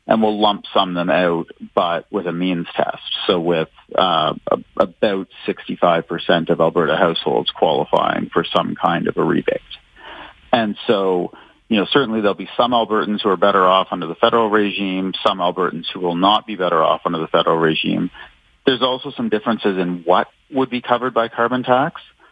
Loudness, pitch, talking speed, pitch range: -18 LUFS, 100 Hz, 185 wpm, 90-115 Hz